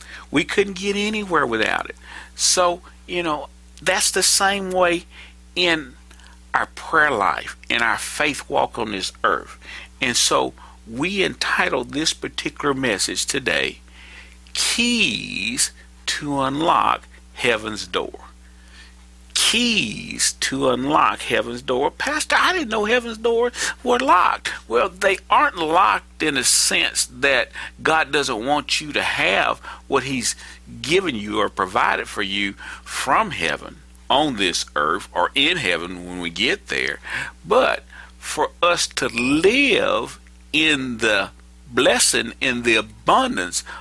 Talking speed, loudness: 130 wpm, -19 LUFS